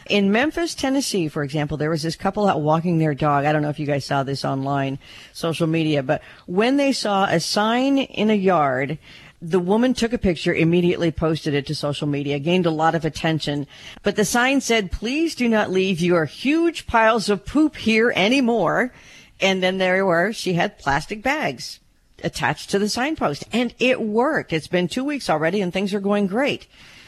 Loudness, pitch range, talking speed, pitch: -21 LUFS, 155-230 Hz, 195 wpm, 185 Hz